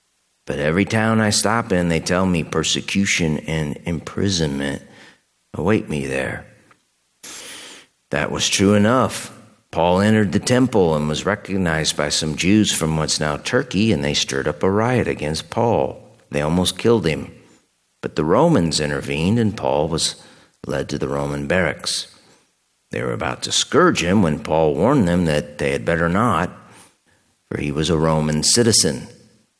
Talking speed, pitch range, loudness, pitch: 160 wpm, 75-100 Hz, -19 LUFS, 85 Hz